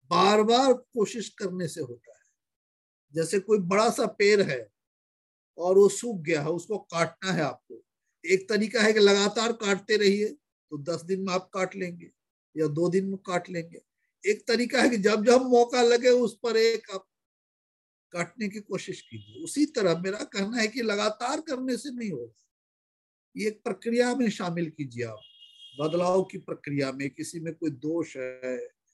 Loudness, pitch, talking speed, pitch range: -26 LUFS, 195 Hz, 175 wpm, 165-230 Hz